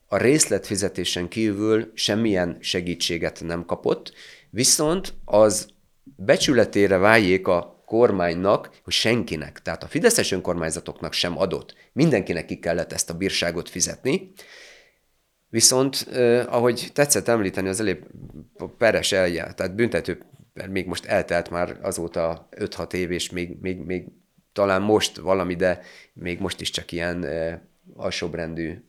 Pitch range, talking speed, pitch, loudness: 85-110 Hz, 130 wpm, 95 Hz, -22 LUFS